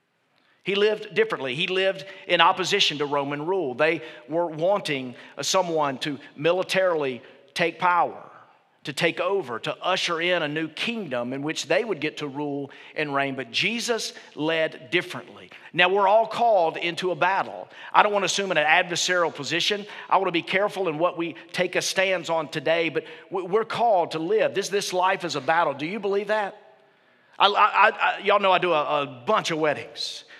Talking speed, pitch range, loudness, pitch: 190 wpm, 155-195 Hz, -24 LUFS, 175 Hz